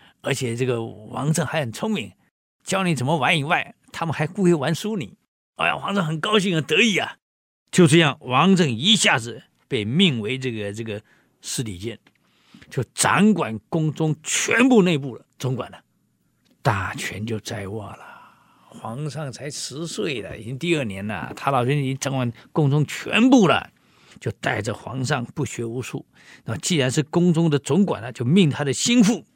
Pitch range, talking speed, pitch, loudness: 125-175 Hz, 260 characters per minute, 150 Hz, -21 LUFS